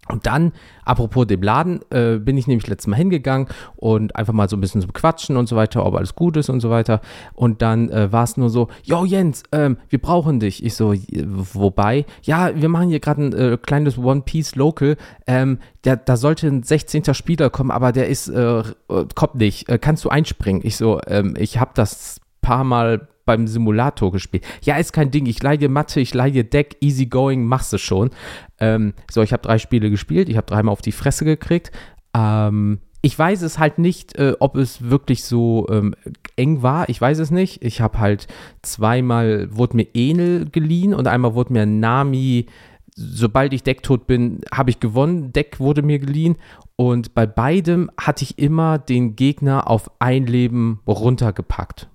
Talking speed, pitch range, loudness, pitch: 195 wpm, 110-145 Hz, -18 LUFS, 125 Hz